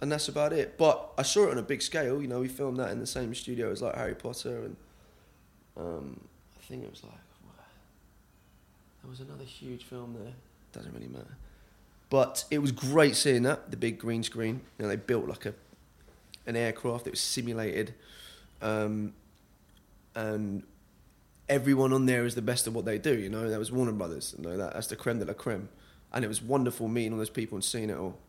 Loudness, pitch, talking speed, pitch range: -31 LUFS, 115 Hz, 215 wpm, 105-130 Hz